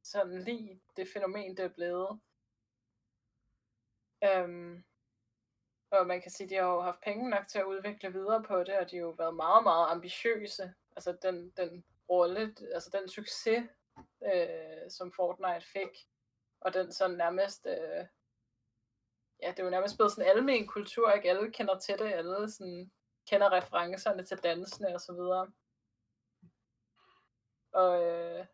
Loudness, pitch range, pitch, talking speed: -33 LUFS, 165-195 Hz, 185 Hz, 160 wpm